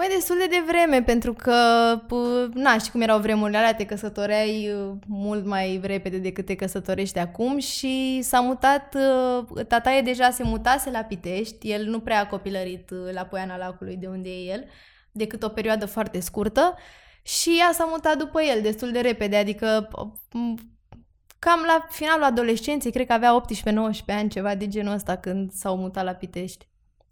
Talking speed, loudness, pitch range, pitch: 170 wpm, -23 LUFS, 195-250 Hz, 220 Hz